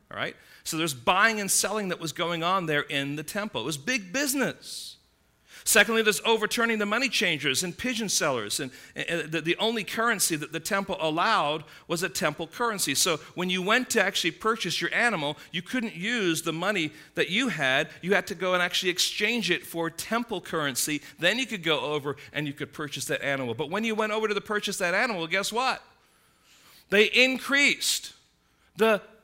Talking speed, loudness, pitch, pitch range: 195 wpm, -26 LUFS, 190 Hz, 160-220 Hz